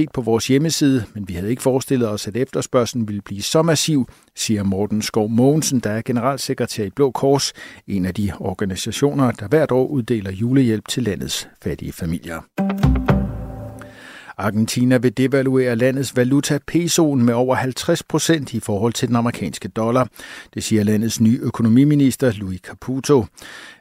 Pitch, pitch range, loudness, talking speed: 125 Hz, 110-135 Hz, -19 LUFS, 155 wpm